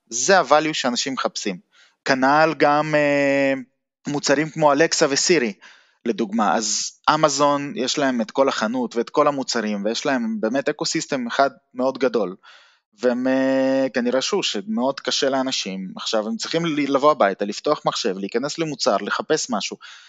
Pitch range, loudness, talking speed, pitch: 125-150 Hz, -21 LUFS, 140 wpm, 140 Hz